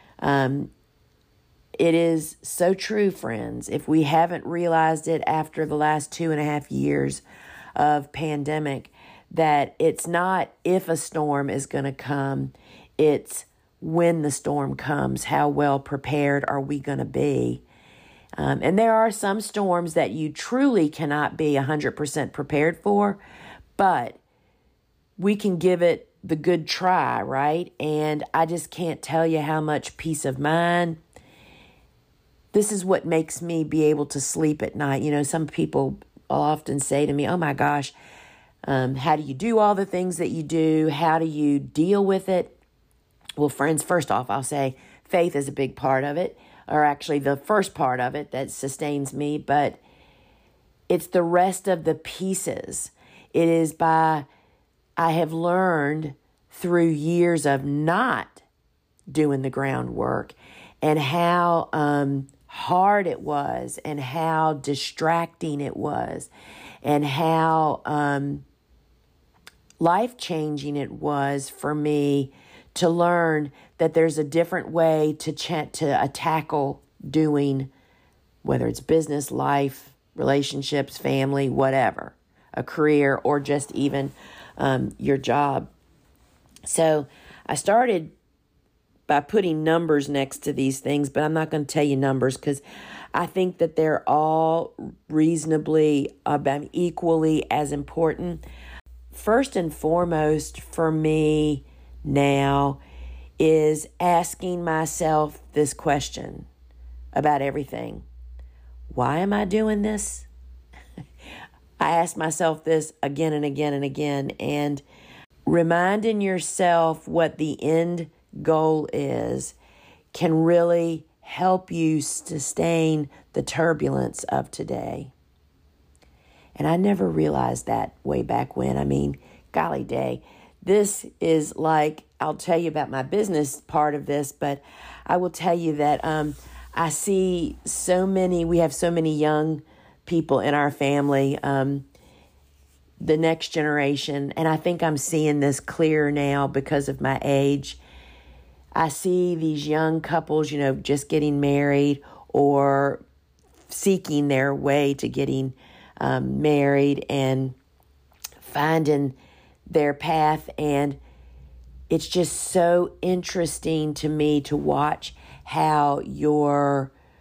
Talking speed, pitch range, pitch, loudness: 135 wpm, 140-165 Hz, 150 Hz, -23 LUFS